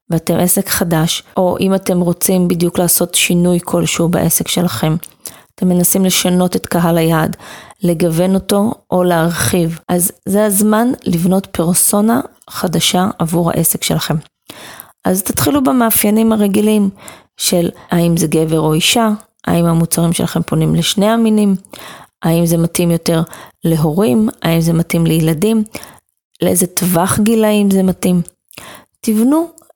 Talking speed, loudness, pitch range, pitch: 125 wpm, -13 LUFS, 170-210 Hz, 180 Hz